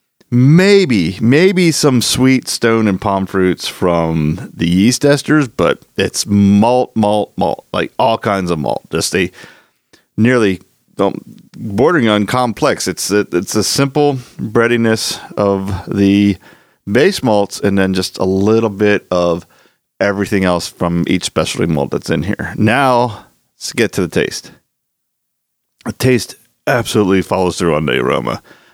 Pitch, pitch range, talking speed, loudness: 105 Hz, 95-120 Hz, 145 wpm, -14 LUFS